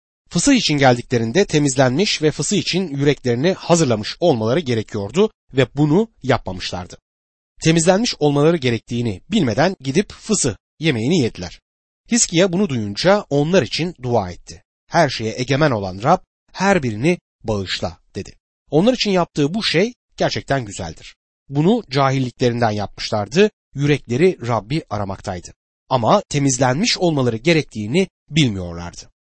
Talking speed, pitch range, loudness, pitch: 115 wpm, 115-175 Hz, -18 LUFS, 140 Hz